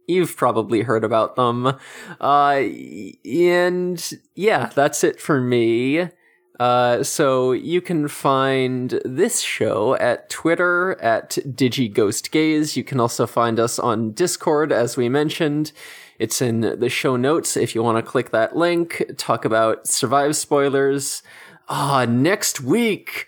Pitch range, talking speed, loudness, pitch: 120-160 Hz, 135 wpm, -19 LUFS, 135 Hz